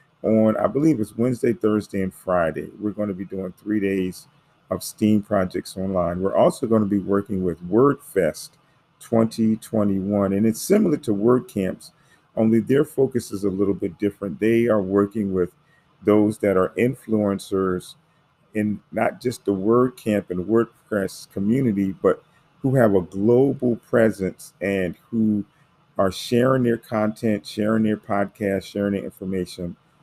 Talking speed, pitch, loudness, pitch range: 150 wpm, 105 Hz, -22 LUFS, 100-115 Hz